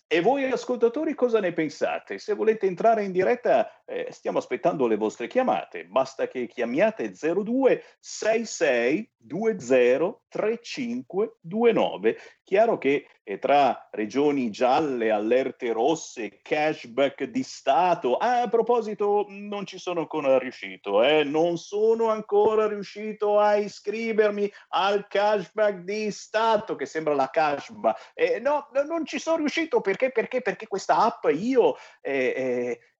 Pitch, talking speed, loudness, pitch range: 215 Hz, 135 wpm, -25 LUFS, 180-255 Hz